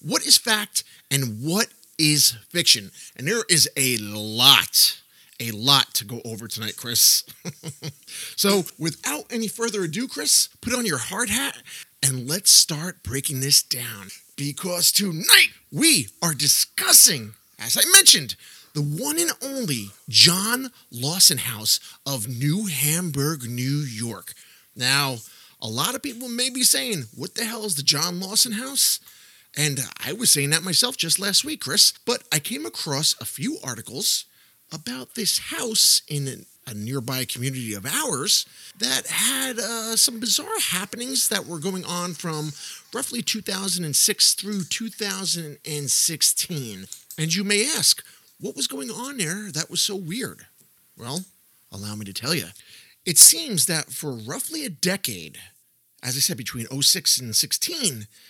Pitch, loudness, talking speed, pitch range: 160 Hz, -19 LUFS, 150 wpm, 130-210 Hz